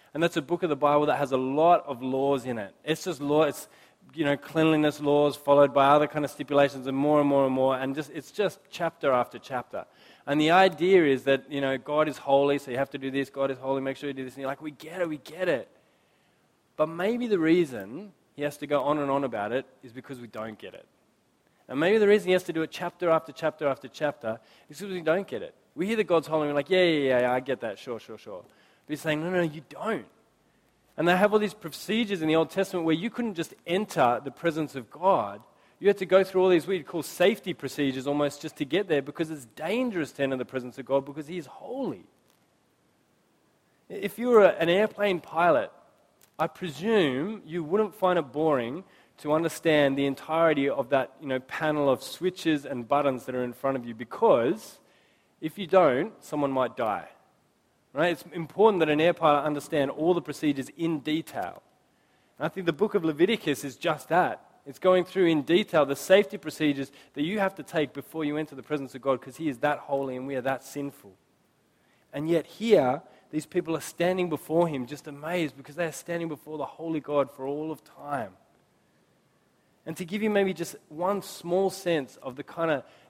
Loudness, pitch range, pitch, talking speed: -27 LUFS, 140-175 Hz, 155 Hz, 225 wpm